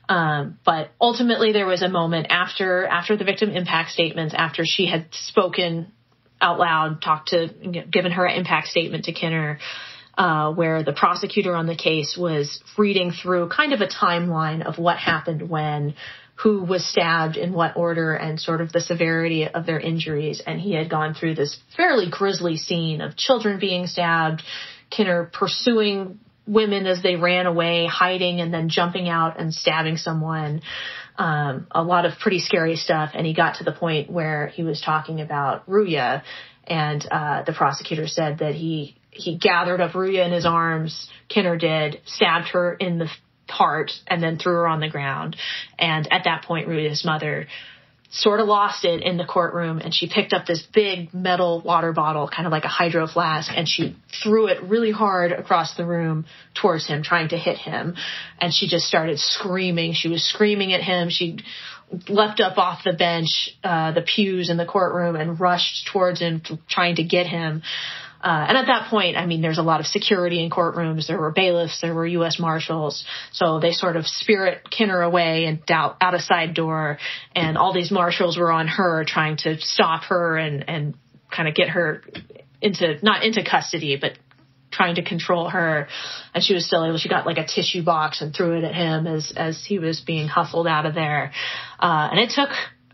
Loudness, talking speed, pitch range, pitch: -21 LUFS, 190 wpm, 160-180 Hz, 170 Hz